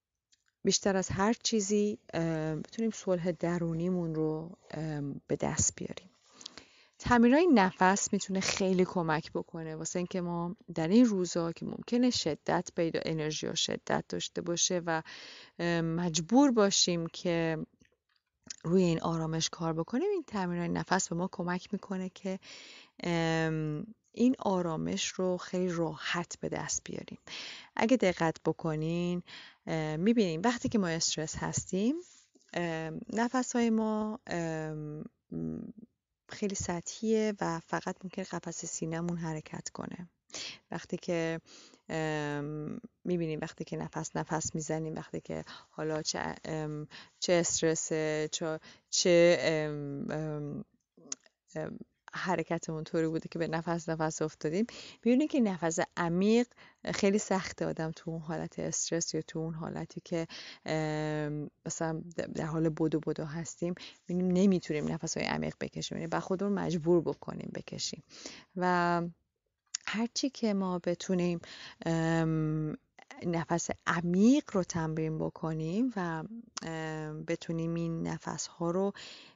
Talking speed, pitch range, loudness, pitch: 115 wpm, 160-195 Hz, -32 LUFS, 170 Hz